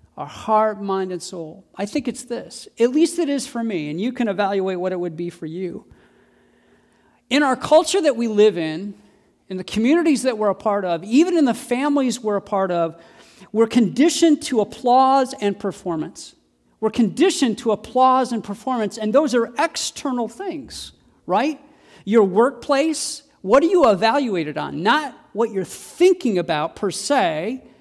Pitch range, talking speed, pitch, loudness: 195-280 Hz, 175 wpm, 230 Hz, -20 LUFS